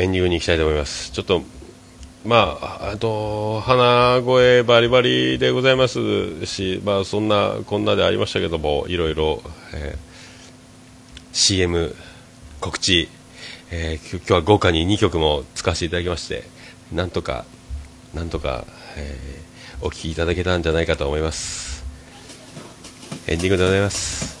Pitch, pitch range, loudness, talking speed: 90 Hz, 80-105 Hz, -20 LUFS, 240 characters per minute